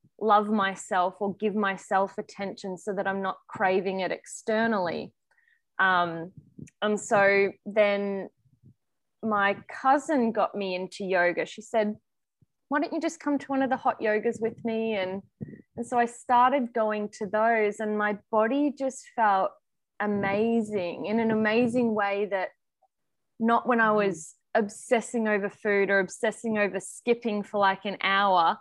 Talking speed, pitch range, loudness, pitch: 150 wpm, 195-230 Hz, -27 LUFS, 210 Hz